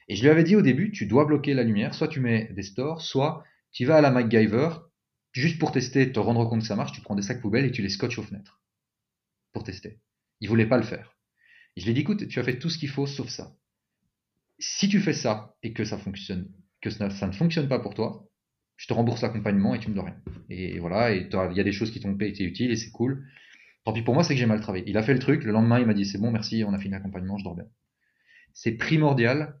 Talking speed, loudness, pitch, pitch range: 280 wpm, -25 LUFS, 115 Hz, 105-140 Hz